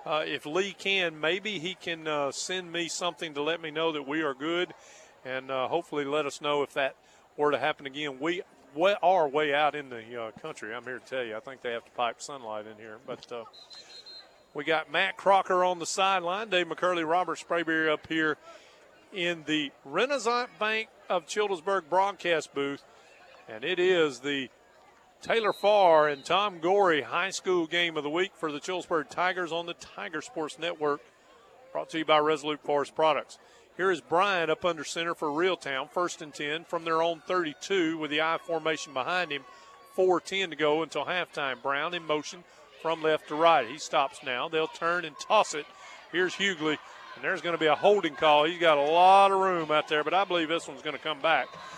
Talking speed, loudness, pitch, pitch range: 205 wpm, -28 LUFS, 165 Hz, 150-180 Hz